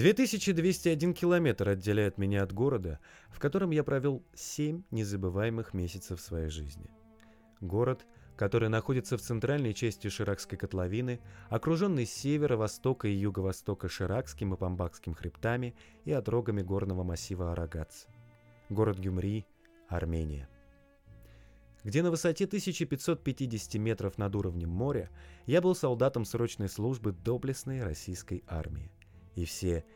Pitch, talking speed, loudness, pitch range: 110 Hz, 115 wpm, -33 LUFS, 95-130 Hz